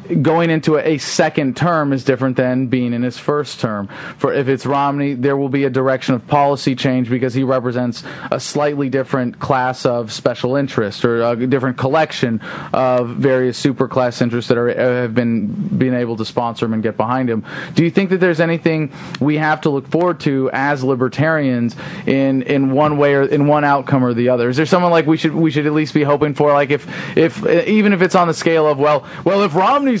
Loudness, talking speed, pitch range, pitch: -16 LUFS, 220 wpm, 125-155 Hz, 140 Hz